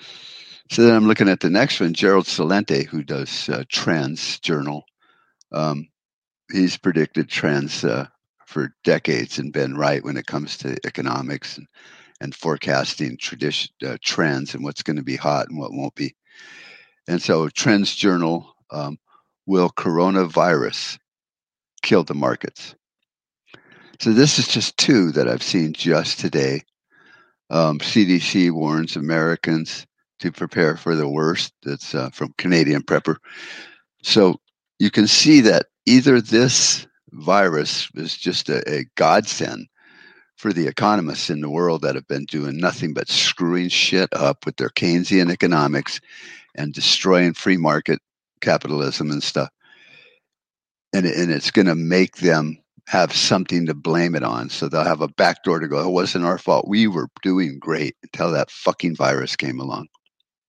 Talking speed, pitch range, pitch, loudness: 155 wpm, 80-100 Hz, 85 Hz, -19 LUFS